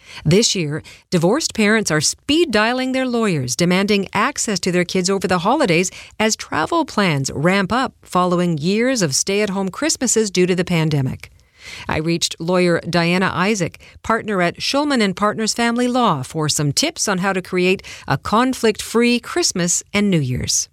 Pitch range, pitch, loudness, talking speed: 175-225 Hz, 195 Hz, -18 LUFS, 160 wpm